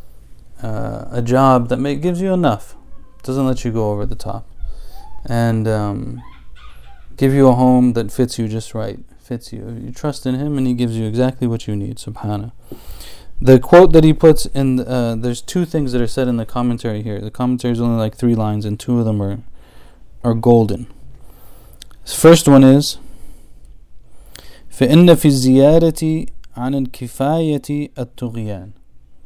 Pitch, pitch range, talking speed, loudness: 120 Hz, 105-135 Hz, 160 wpm, -15 LUFS